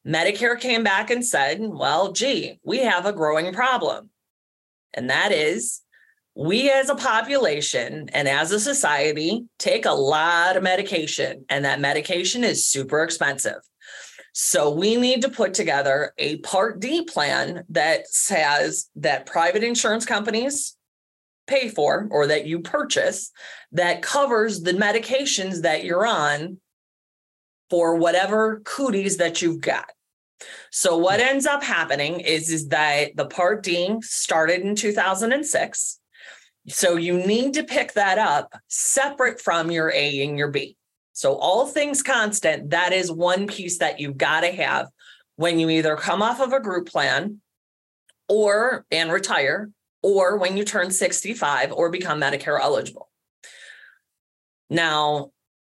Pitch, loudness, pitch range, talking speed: 185 Hz, -21 LUFS, 160-230 Hz, 140 wpm